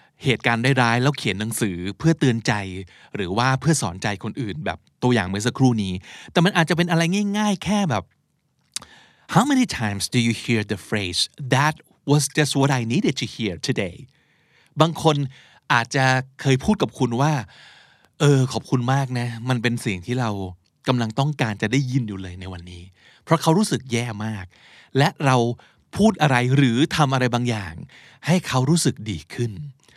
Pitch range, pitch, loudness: 110-150 Hz, 130 Hz, -21 LUFS